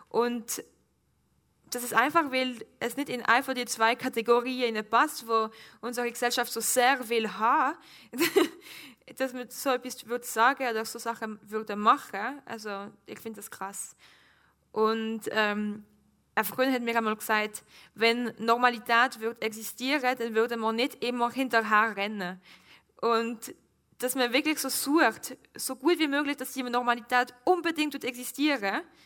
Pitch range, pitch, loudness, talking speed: 220-255 Hz, 235 Hz, -28 LUFS, 155 wpm